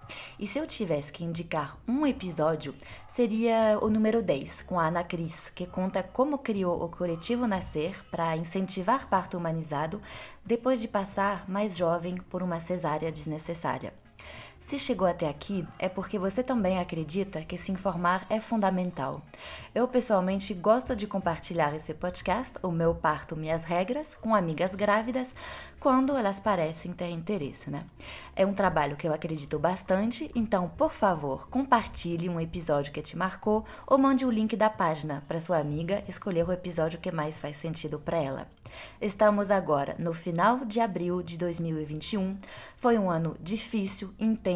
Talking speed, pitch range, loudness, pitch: 160 wpm, 165-215 Hz, -29 LUFS, 185 Hz